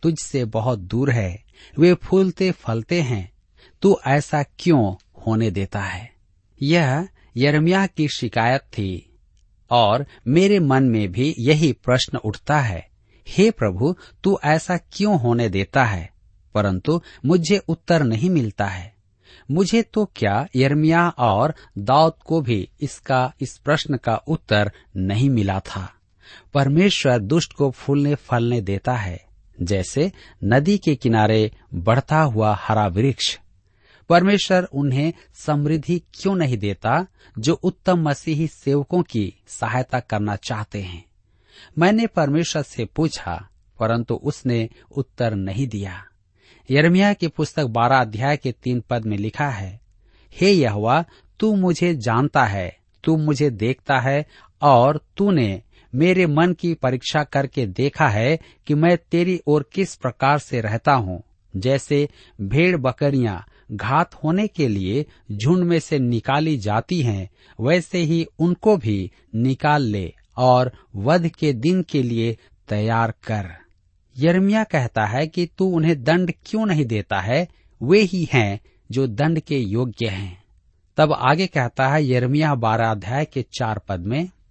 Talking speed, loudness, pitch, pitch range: 135 wpm, -20 LUFS, 130 Hz, 105-160 Hz